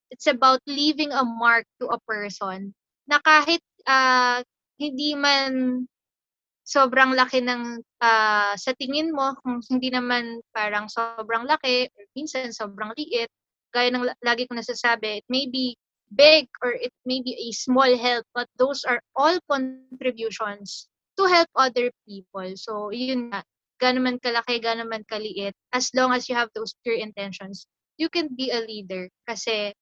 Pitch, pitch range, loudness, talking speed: 245 Hz, 225-265 Hz, -23 LUFS, 155 wpm